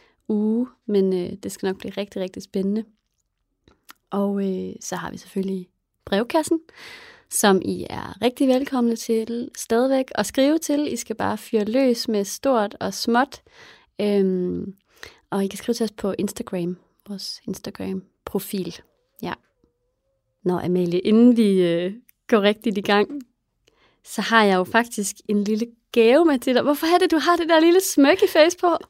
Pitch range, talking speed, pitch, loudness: 195-260 Hz, 160 wpm, 220 Hz, -21 LUFS